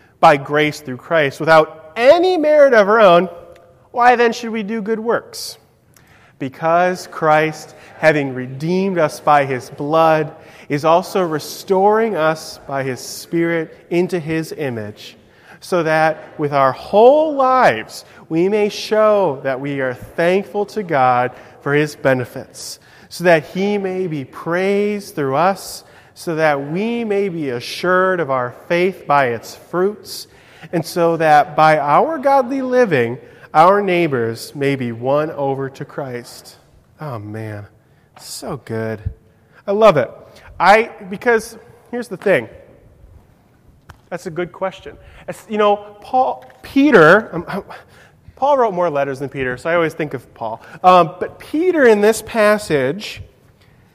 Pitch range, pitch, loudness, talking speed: 140-205 Hz, 165 Hz, -16 LUFS, 140 wpm